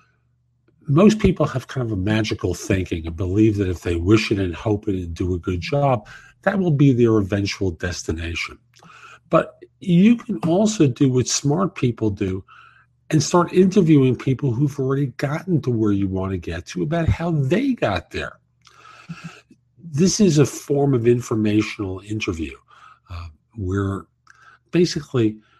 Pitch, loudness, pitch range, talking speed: 120 Hz, -20 LUFS, 95-155 Hz, 155 wpm